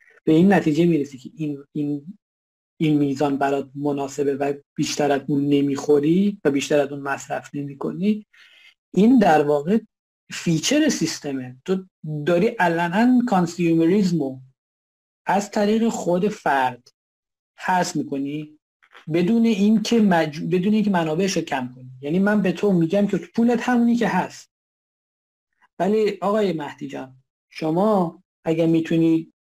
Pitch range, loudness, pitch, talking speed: 145-205 Hz, -21 LUFS, 165 Hz, 130 wpm